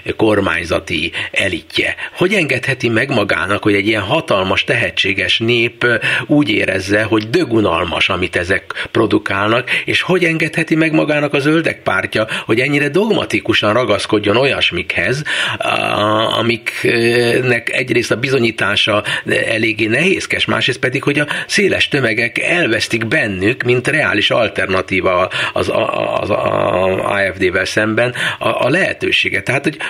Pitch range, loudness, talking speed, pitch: 110-160 Hz, -14 LUFS, 120 wpm, 120 Hz